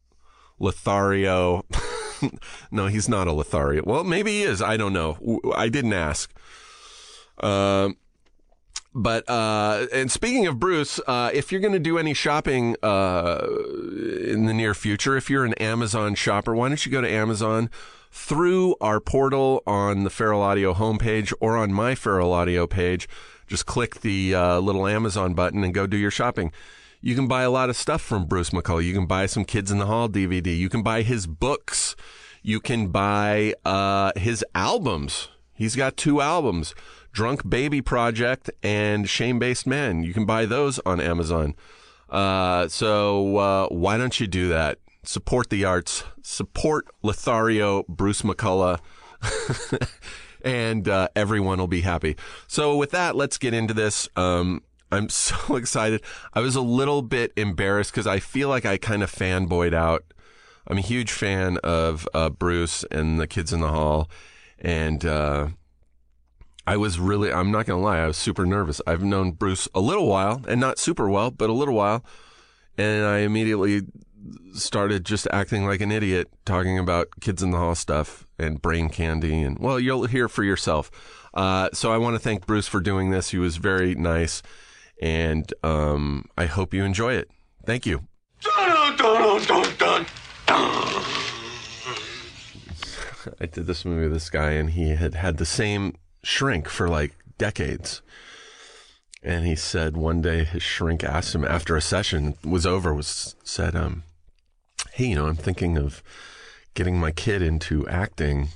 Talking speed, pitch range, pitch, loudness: 165 wpm, 85-110 Hz, 100 Hz, -24 LUFS